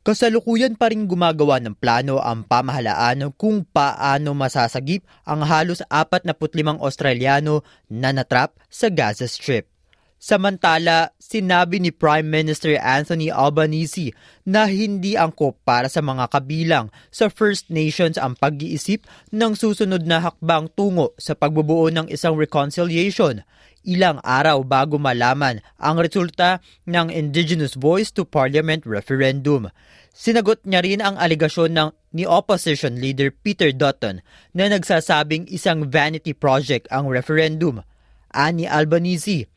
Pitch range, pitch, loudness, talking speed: 140-180 Hz, 155 Hz, -19 LUFS, 125 wpm